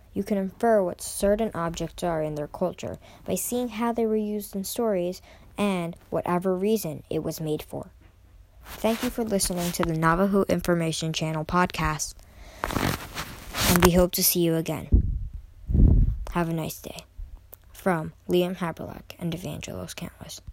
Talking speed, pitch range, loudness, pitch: 150 wpm, 150-195 Hz, -26 LUFS, 170 Hz